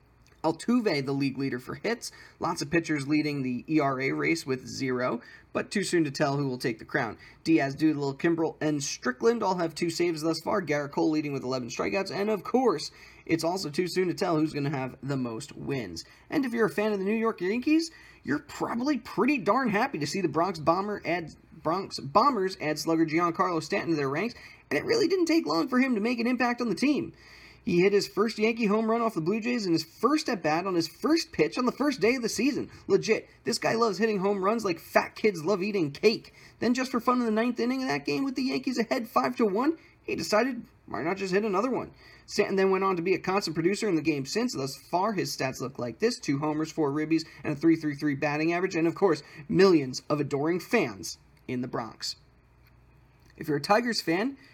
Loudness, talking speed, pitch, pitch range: -28 LUFS, 235 wpm, 175 Hz, 150-220 Hz